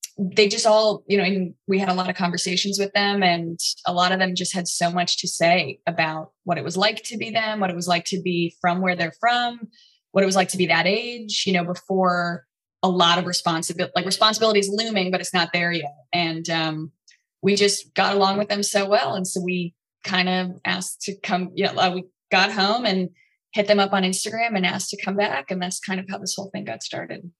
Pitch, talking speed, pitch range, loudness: 185 Hz, 250 wpm, 175-200 Hz, -22 LUFS